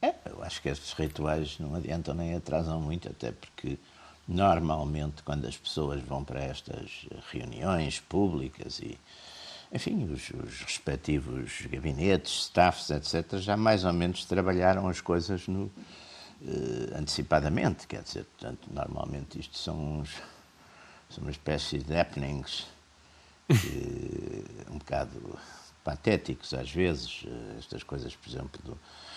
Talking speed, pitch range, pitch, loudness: 130 wpm, 75-85 Hz, 80 Hz, -32 LUFS